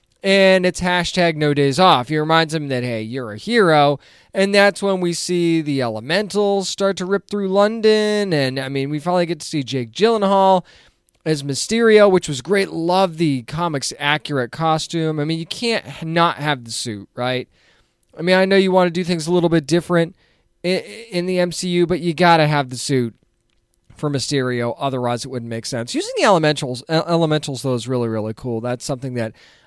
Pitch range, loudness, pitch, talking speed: 135-185 Hz, -18 LUFS, 165 Hz, 200 wpm